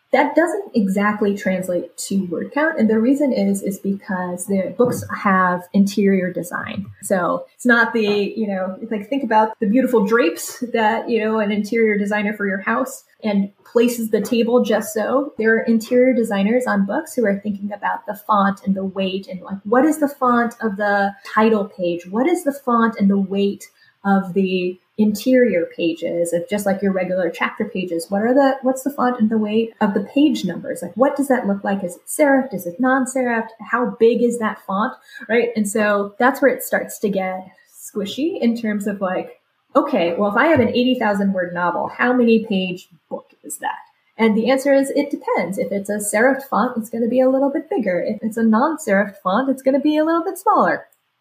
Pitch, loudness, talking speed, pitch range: 220 Hz, -19 LUFS, 210 wpm, 200-260 Hz